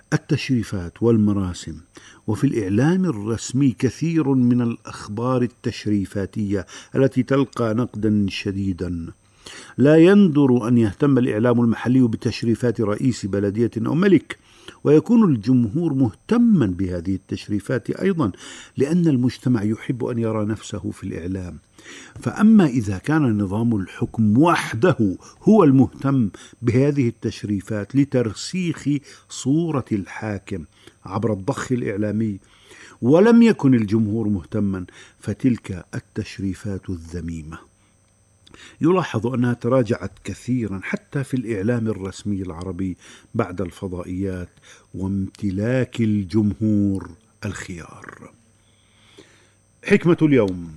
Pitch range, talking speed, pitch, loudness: 100-130 Hz, 90 wpm, 110 Hz, -20 LUFS